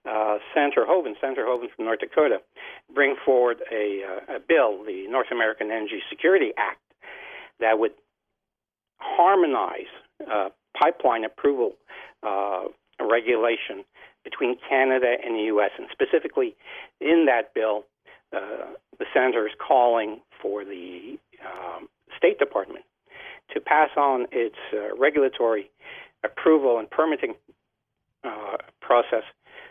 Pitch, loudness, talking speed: 145 Hz, -24 LUFS, 120 wpm